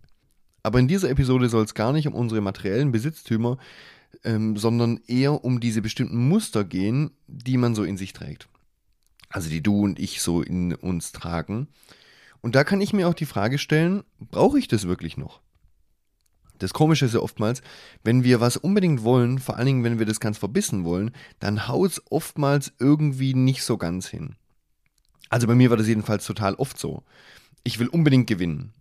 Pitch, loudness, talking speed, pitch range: 120 Hz, -23 LUFS, 185 wpm, 105-140 Hz